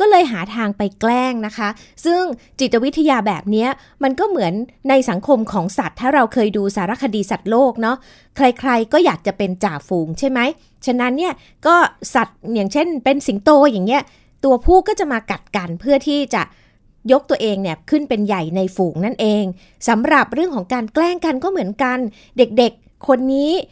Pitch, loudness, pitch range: 245 Hz, -17 LUFS, 210-280 Hz